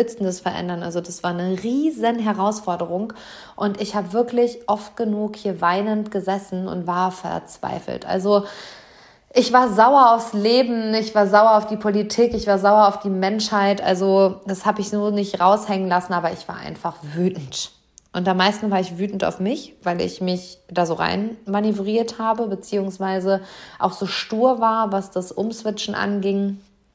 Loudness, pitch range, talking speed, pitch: -20 LUFS, 185-215 Hz, 165 wpm, 200 Hz